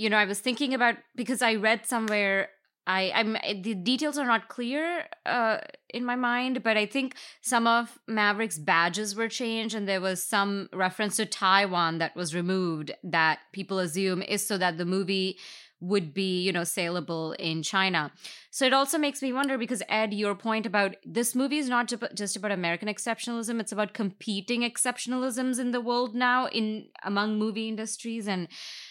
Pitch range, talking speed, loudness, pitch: 195-240 Hz, 180 wpm, -28 LUFS, 215 Hz